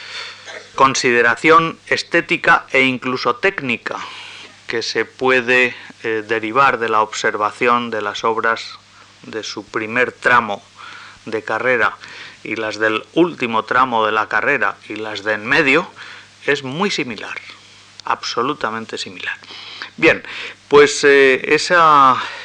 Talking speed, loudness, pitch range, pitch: 120 wpm, -16 LUFS, 110-135 Hz, 120 Hz